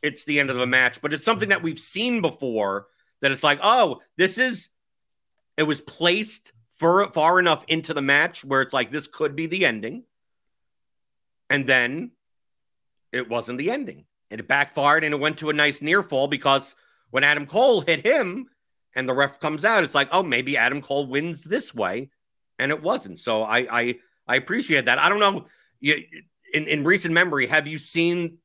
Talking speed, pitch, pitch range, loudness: 195 wpm, 150 Hz, 135-170 Hz, -22 LUFS